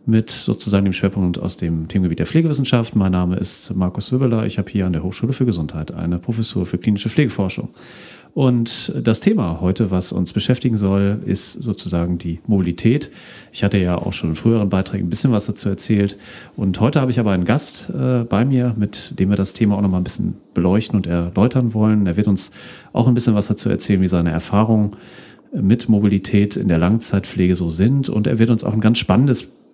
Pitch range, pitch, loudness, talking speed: 90-115 Hz, 100 Hz, -18 LUFS, 205 wpm